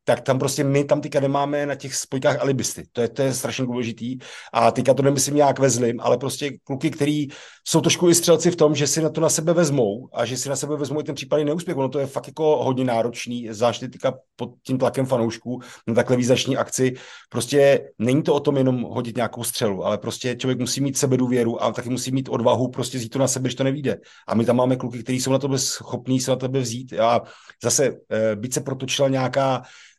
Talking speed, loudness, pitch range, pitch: 235 wpm, -22 LUFS, 125-140 Hz, 130 Hz